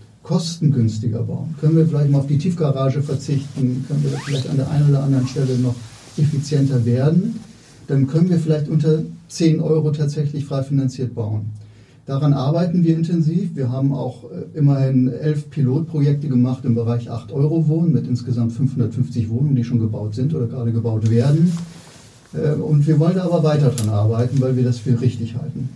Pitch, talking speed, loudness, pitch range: 140 Hz, 170 wpm, -19 LUFS, 125-155 Hz